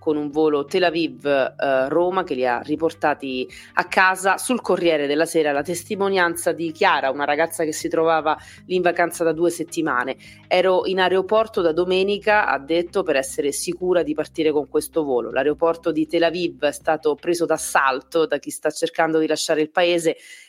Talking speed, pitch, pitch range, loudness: 180 wpm, 165 Hz, 150-175 Hz, -21 LUFS